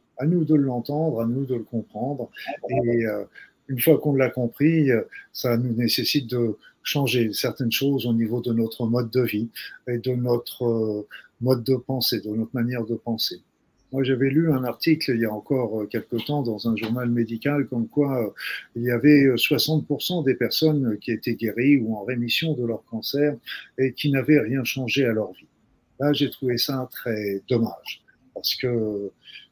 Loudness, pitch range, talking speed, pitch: -24 LUFS, 115-140 Hz, 180 wpm, 125 Hz